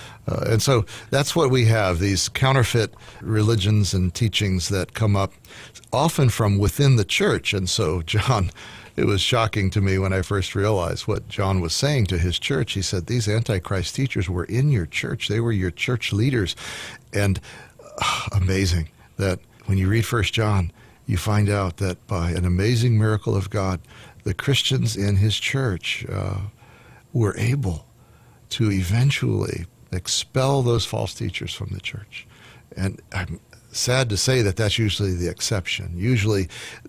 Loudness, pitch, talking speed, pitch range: -22 LUFS, 105 Hz, 165 wpm, 95-120 Hz